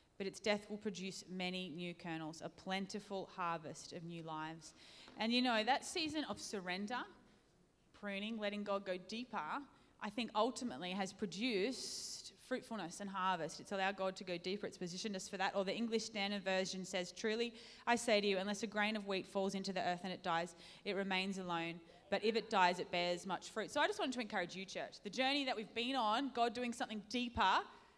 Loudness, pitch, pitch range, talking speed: -41 LUFS, 200 Hz, 185-225 Hz, 210 wpm